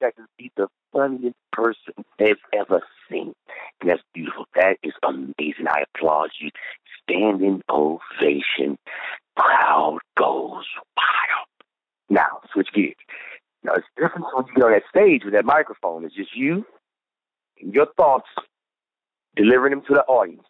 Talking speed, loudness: 145 wpm, -21 LUFS